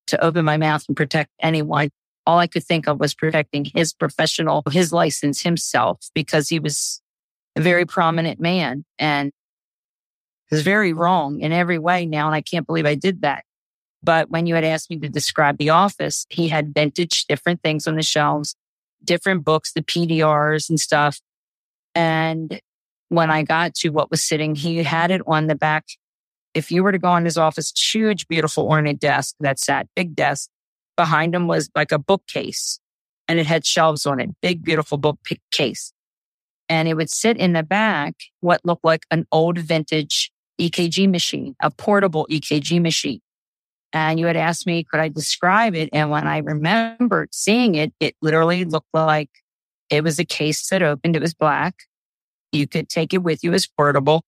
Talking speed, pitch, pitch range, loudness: 180 wpm, 160 Hz, 155-170 Hz, -19 LUFS